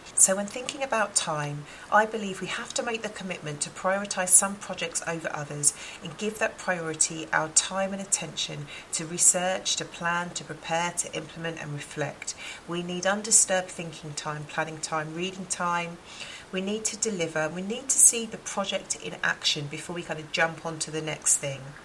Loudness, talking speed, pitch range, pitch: -26 LUFS, 185 wpm, 160-195 Hz, 175 Hz